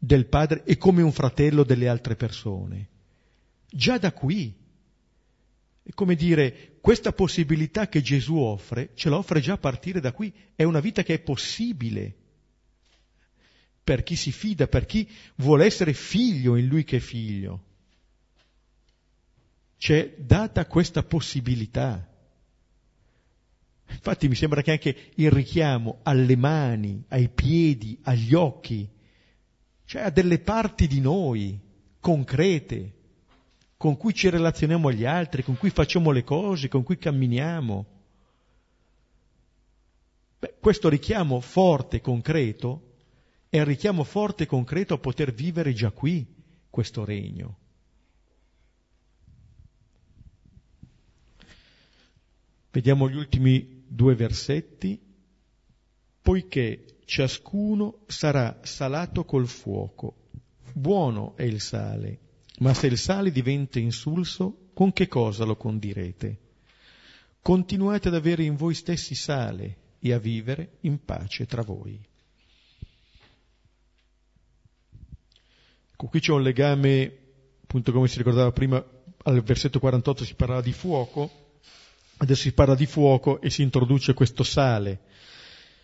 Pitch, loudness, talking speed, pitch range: 135 Hz, -24 LUFS, 120 wpm, 115-160 Hz